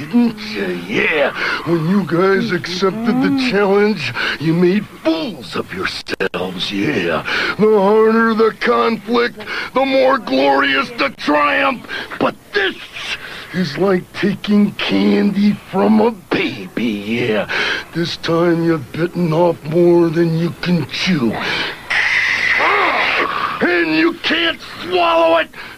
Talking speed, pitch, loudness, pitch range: 115 wpm, 200 Hz, -16 LUFS, 170-240 Hz